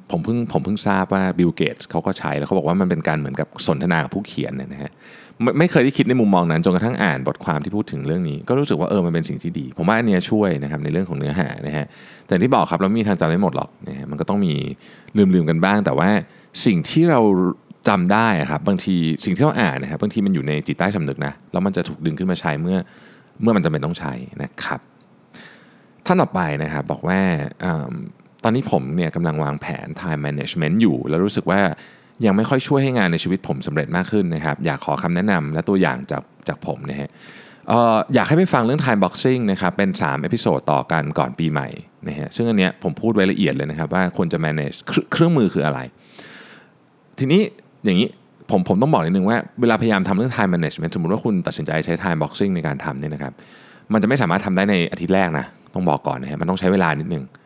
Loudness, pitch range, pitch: -20 LUFS, 75-105 Hz, 90 Hz